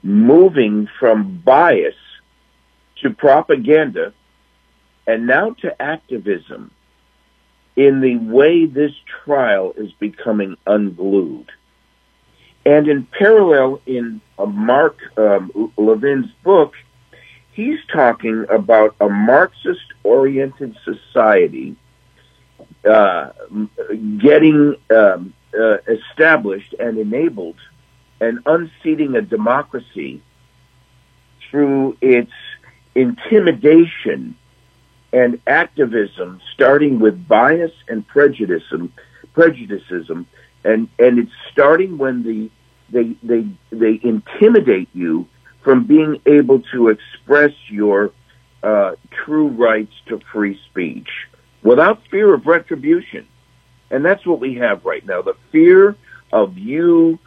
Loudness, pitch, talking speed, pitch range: -14 LUFS, 130 Hz, 95 wpm, 110-170 Hz